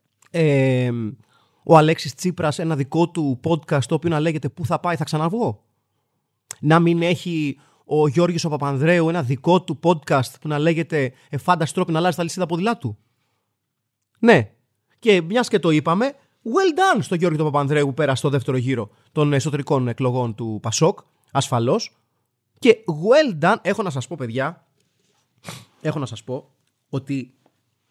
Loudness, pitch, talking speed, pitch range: -20 LUFS, 150 Hz, 160 wpm, 130-170 Hz